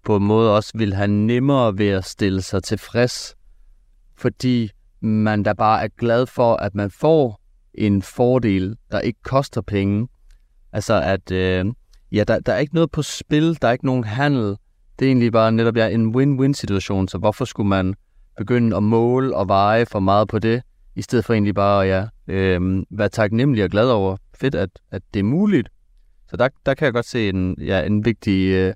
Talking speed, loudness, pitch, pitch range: 200 wpm, -19 LUFS, 105 Hz, 95-120 Hz